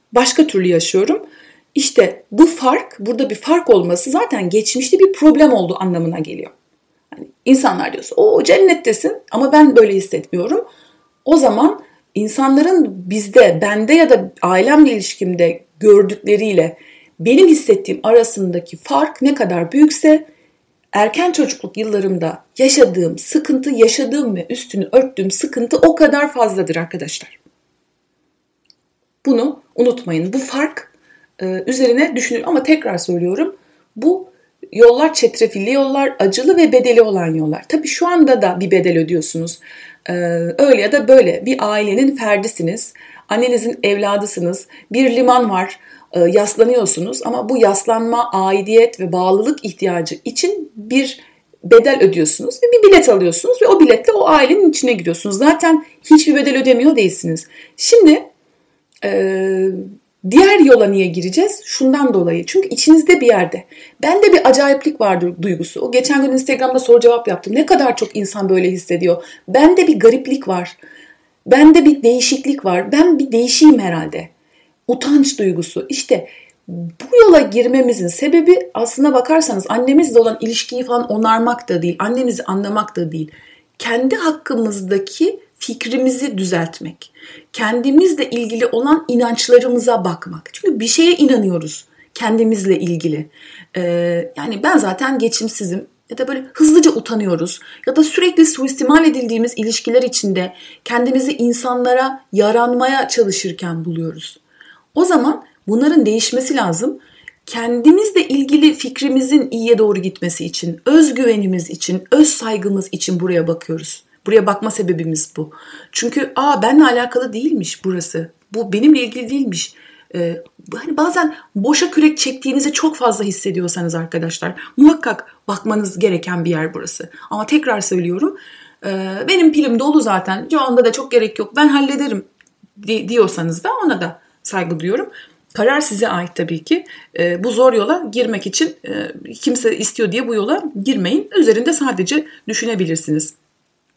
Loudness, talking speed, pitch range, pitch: -14 LUFS, 130 wpm, 190-290 Hz, 240 Hz